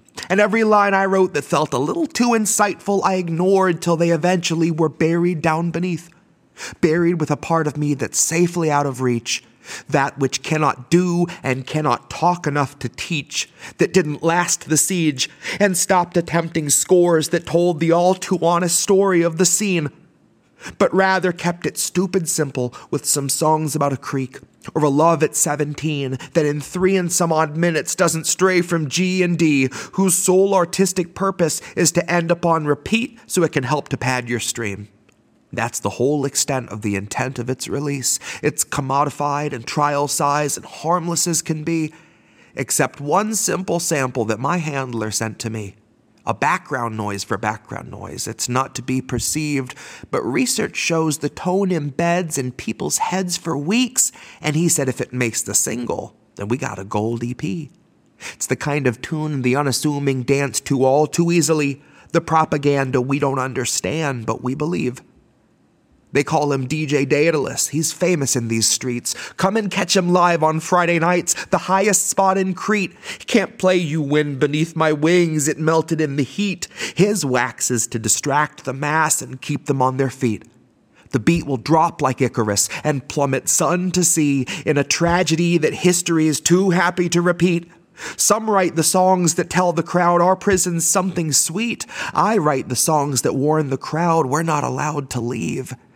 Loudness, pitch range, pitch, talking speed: -19 LUFS, 135-175 Hz, 155 Hz, 180 wpm